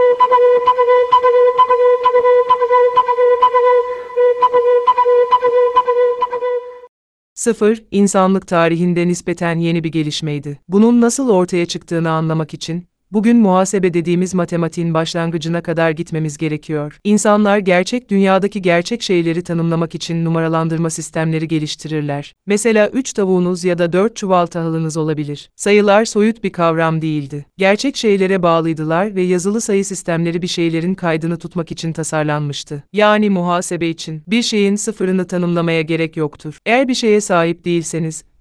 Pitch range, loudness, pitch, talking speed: 165-225 Hz, -15 LUFS, 180 Hz, 110 wpm